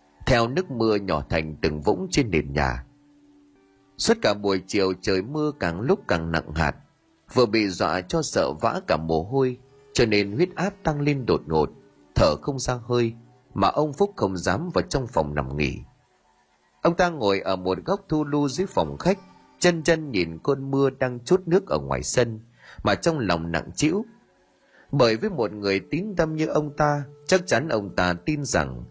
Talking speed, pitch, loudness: 195 wpm, 115 Hz, -24 LUFS